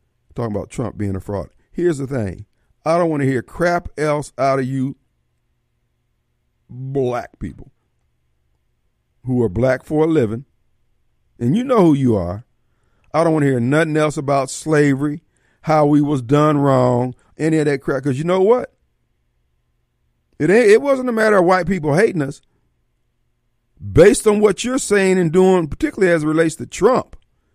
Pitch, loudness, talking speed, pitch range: 135 Hz, -17 LUFS, 170 wpm, 95-160 Hz